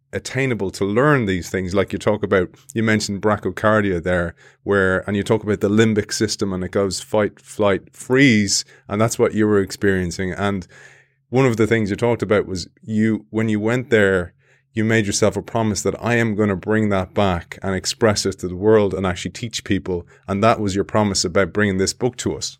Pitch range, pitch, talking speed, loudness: 95-115 Hz, 105 Hz, 215 wpm, -19 LUFS